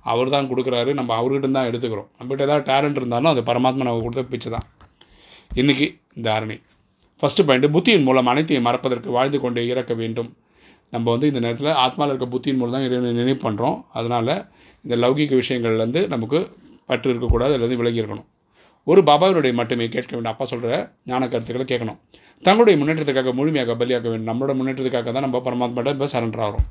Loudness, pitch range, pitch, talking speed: -20 LUFS, 120-135 Hz, 125 Hz, 160 wpm